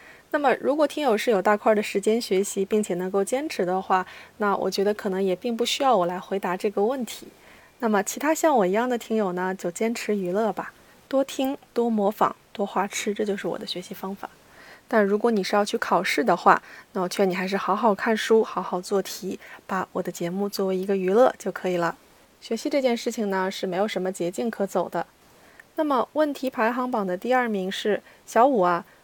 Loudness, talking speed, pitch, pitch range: -24 LUFS, 310 characters per minute, 205 Hz, 185-235 Hz